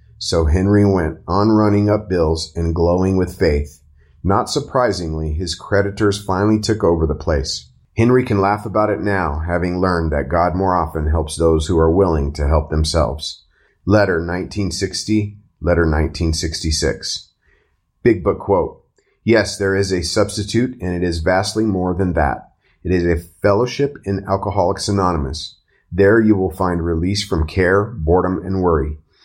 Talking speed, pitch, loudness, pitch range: 155 wpm, 90 Hz, -18 LUFS, 80-100 Hz